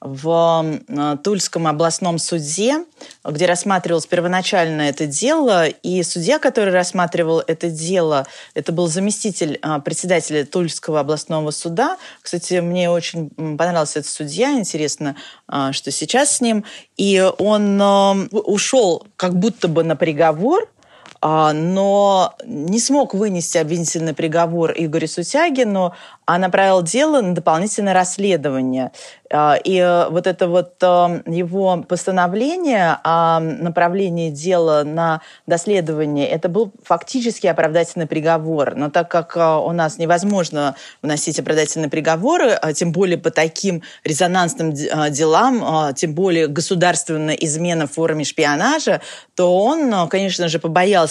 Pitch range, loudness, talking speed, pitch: 160-195 Hz, -17 LUFS, 115 wpm, 175 Hz